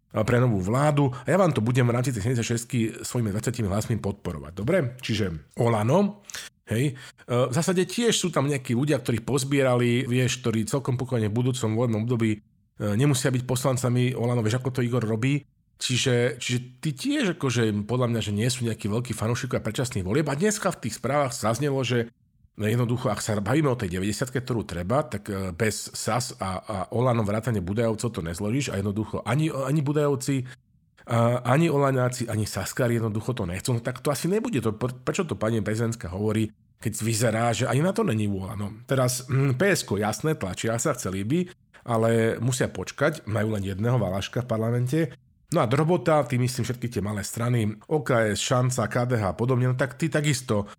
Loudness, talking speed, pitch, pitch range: -25 LUFS, 180 wpm, 120 Hz, 110-135 Hz